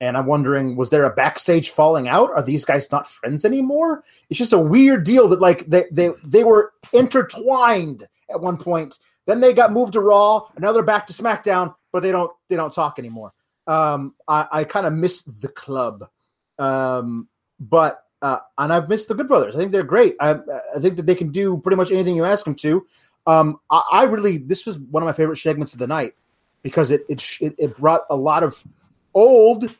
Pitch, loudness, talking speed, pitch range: 175 Hz, -18 LUFS, 215 wpm, 150-210 Hz